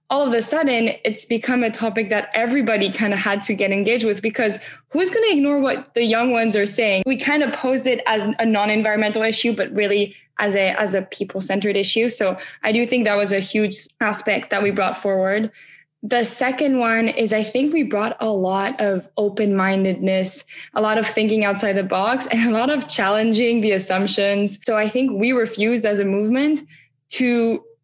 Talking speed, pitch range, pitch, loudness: 205 wpm, 200-240 Hz, 220 Hz, -19 LUFS